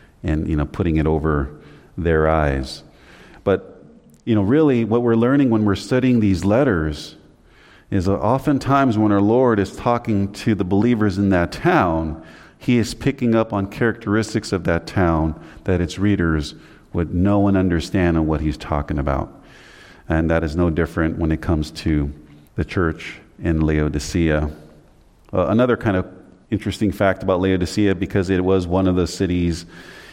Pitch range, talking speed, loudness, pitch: 80-105 Hz, 165 wpm, -19 LUFS, 90 Hz